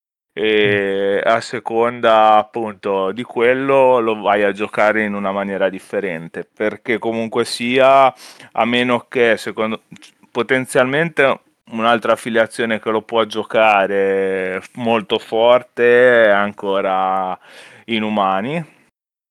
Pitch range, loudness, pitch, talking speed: 100-120 Hz, -16 LUFS, 110 Hz, 105 wpm